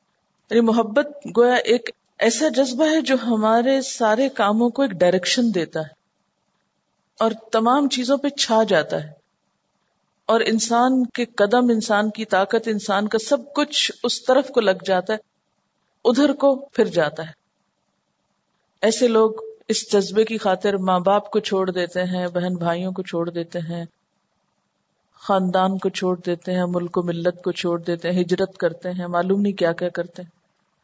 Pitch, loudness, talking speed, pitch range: 205 Hz, -20 LUFS, 160 wpm, 180-235 Hz